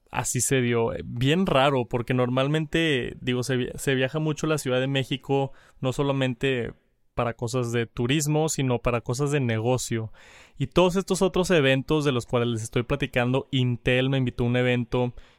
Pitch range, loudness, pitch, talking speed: 125-145 Hz, -25 LUFS, 130 Hz, 170 wpm